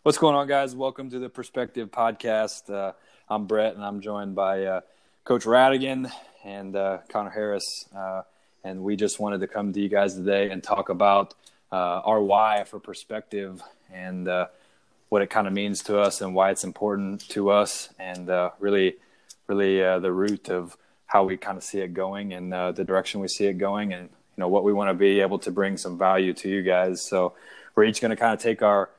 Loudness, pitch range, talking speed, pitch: -25 LUFS, 95-105 Hz, 215 wpm, 100 Hz